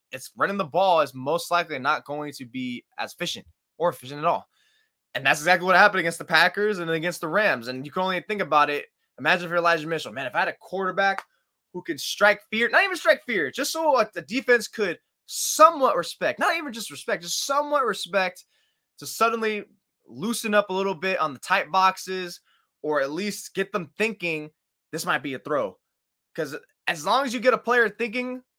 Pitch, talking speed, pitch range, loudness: 190 Hz, 210 wpm, 165-230 Hz, -24 LUFS